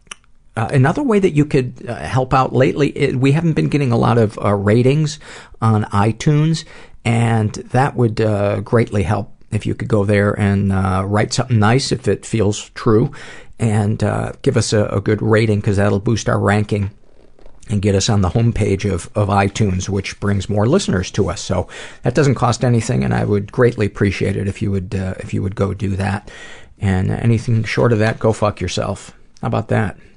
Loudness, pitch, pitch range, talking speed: -17 LUFS, 110 Hz, 100-125 Hz, 205 wpm